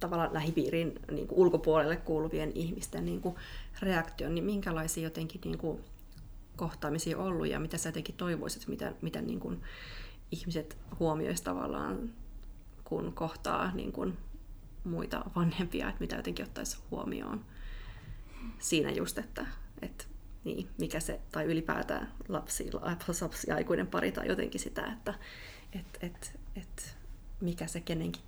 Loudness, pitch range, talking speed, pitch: -36 LUFS, 160-180 Hz, 135 wpm, 165 Hz